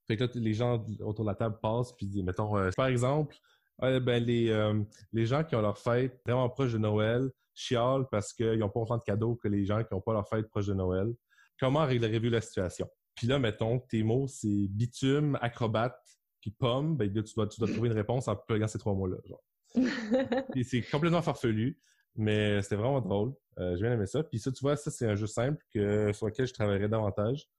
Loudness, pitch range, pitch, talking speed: -31 LUFS, 105-125 Hz, 115 Hz, 235 wpm